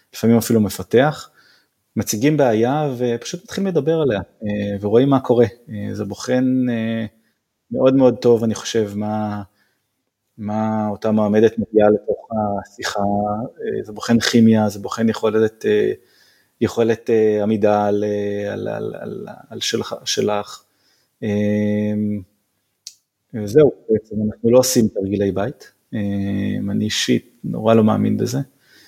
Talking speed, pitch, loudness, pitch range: 110 wpm, 110 Hz, -19 LUFS, 105-120 Hz